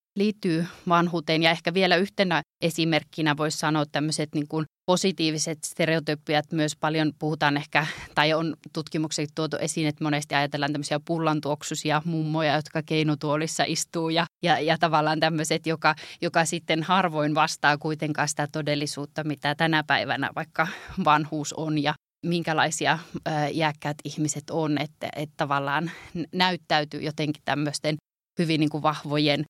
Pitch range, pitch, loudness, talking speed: 150-165 Hz, 155 Hz, -25 LUFS, 140 wpm